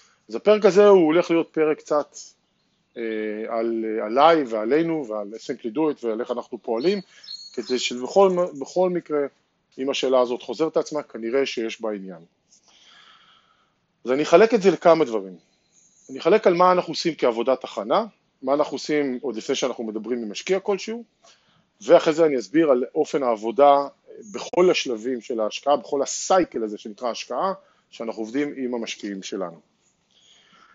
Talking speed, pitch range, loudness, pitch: 150 wpm, 115-170 Hz, -22 LUFS, 140 Hz